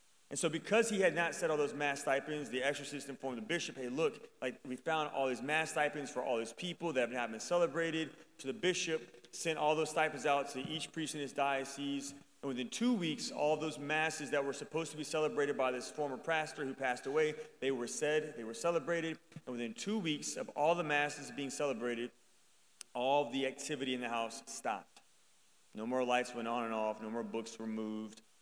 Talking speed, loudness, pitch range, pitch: 215 wpm, -37 LUFS, 125-160 Hz, 145 Hz